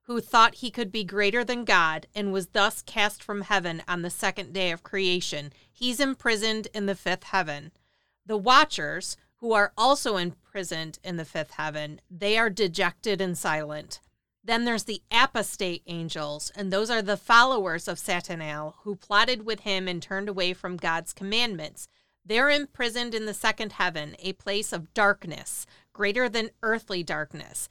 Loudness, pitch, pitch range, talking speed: -26 LUFS, 200 Hz, 175-220 Hz, 165 wpm